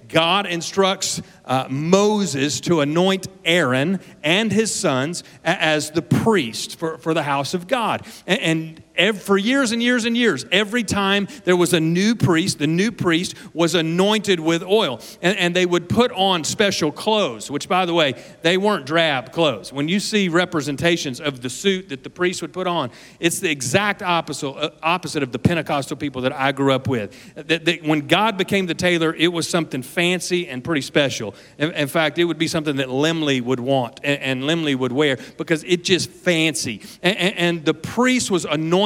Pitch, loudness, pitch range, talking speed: 170 Hz, -20 LUFS, 150-185 Hz, 195 wpm